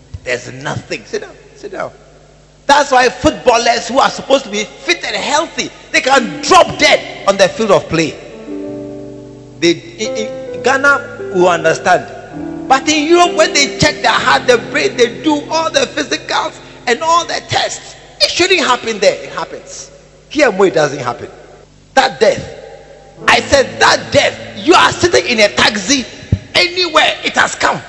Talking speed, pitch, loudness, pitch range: 160 wpm, 270 Hz, -12 LUFS, 195-320 Hz